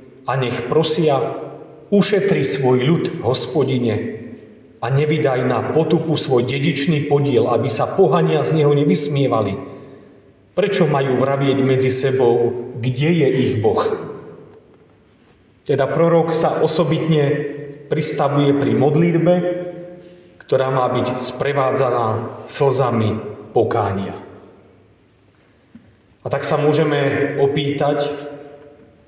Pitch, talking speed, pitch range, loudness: 140 Hz, 95 wpm, 125-155 Hz, -18 LUFS